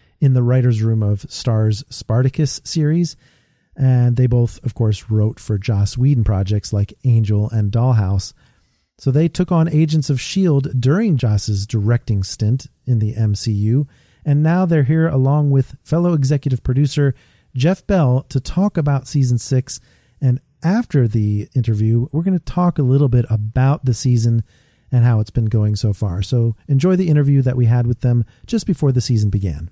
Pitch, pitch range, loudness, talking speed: 125 Hz, 110-145 Hz, -17 LUFS, 175 wpm